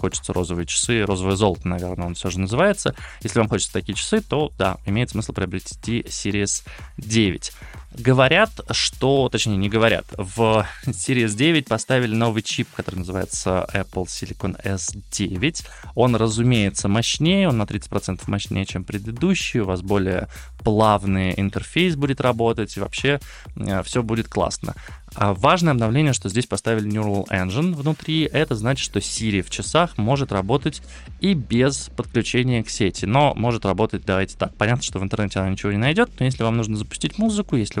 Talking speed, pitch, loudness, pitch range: 160 wpm, 110 Hz, -21 LUFS, 95-130 Hz